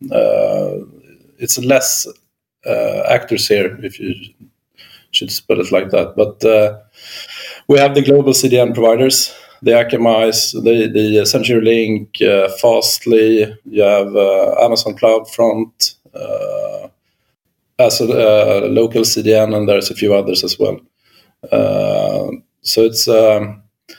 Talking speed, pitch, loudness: 130 wpm, 115 Hz, -13 LUFS